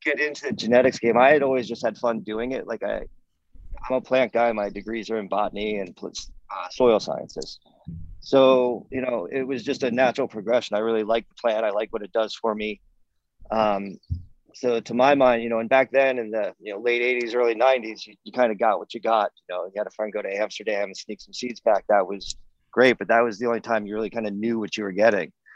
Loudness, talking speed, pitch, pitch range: -23 LUFS, 250 wpm, 115 Hz, 105-125 Hz